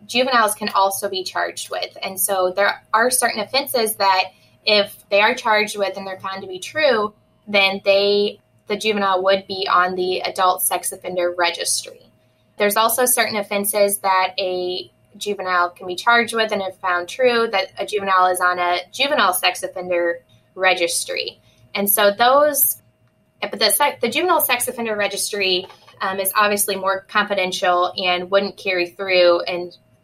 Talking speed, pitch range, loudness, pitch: 160 wpm, 180-215 Hz, -18 LUFS, 195 Hz